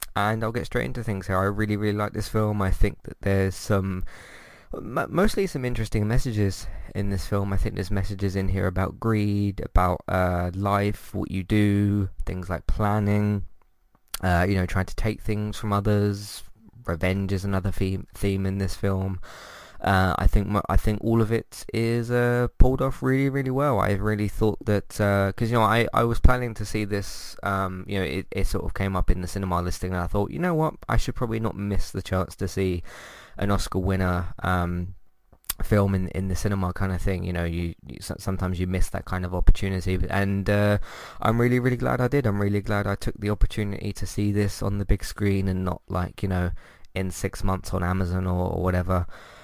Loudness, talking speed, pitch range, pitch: -26 LUFS, 215 wpm, 95-105 Hz, 100 Hz